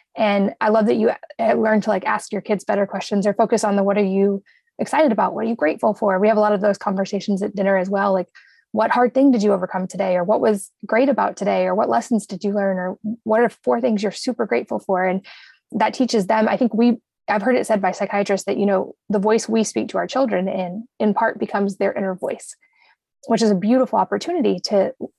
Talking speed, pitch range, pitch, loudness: 245 wpm, 195-225 Hz, 210 Hz, -20 LUFS